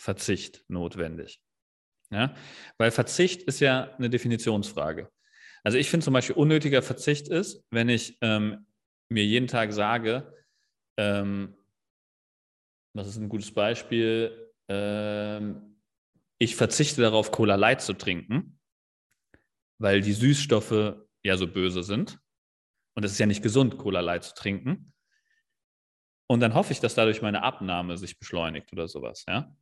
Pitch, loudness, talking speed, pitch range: 110 Hz, -27 LUFS, 140 wpm, 100-125 Hz